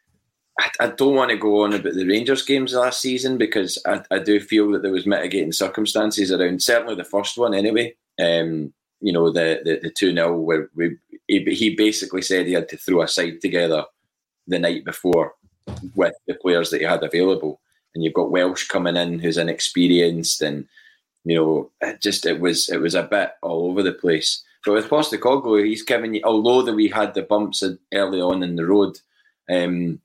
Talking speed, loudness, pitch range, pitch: 200 wpm, -20 LUFS, 85-110 Hz, 100 Hz